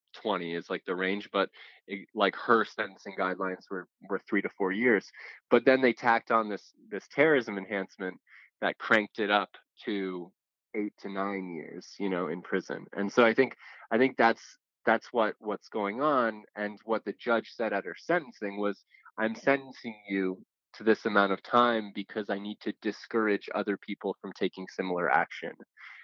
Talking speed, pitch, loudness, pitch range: 180 wpm, 100 Hz, -30 LUFS, 95-110 Hz